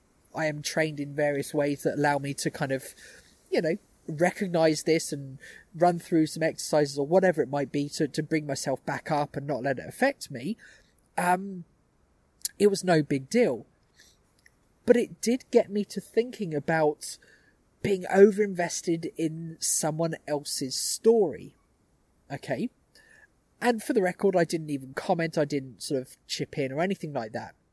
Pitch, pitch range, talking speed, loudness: 160 Hz, 145-190 Hz, 170 wpm, -27 LUFS